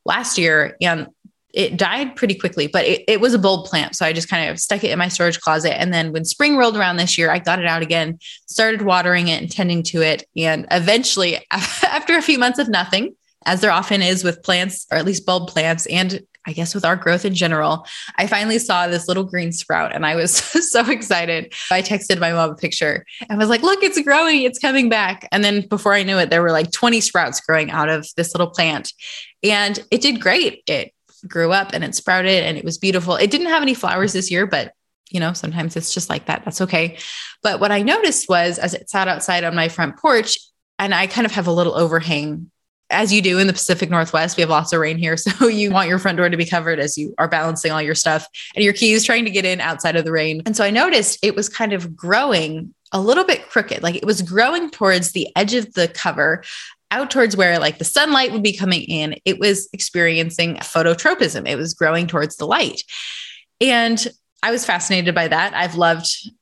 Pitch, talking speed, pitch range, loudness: 180 Hz, 235 wpm, 165-210 Hz, -17 LUFS